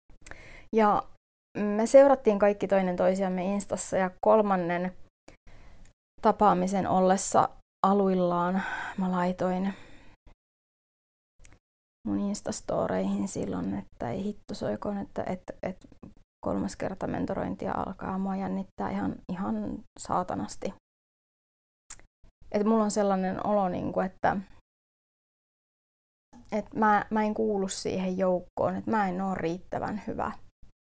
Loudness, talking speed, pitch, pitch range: -28 LUFS, 100 wpm, 190 Hz, 175-205 Hz